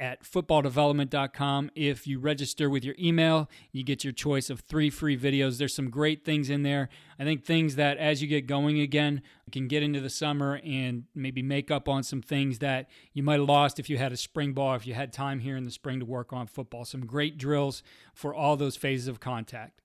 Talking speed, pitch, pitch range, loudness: 225 wpm, 140 Hz, 135-150 Hz, -29 LUFS